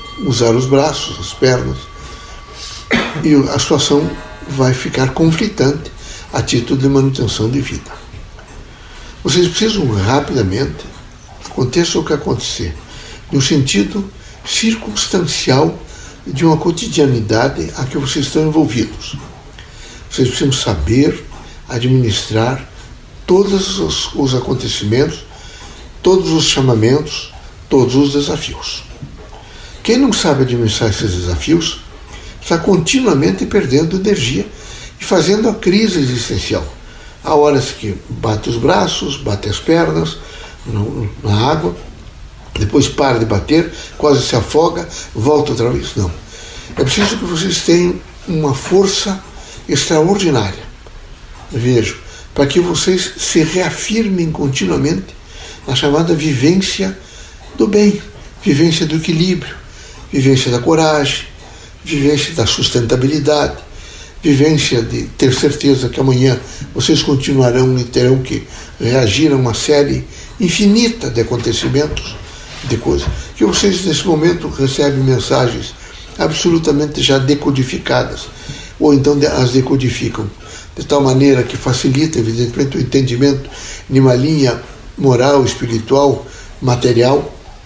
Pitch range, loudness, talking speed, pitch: 115-155 Hz, -14 LUFS, 110 wpm, 135 Hz